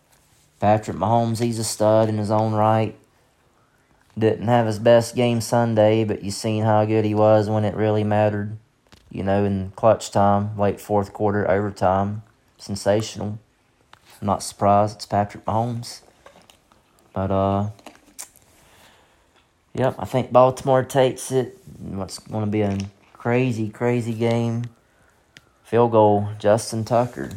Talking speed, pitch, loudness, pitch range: 135 wpm, 110 Hz, -21 LUFS, 100-115 Hz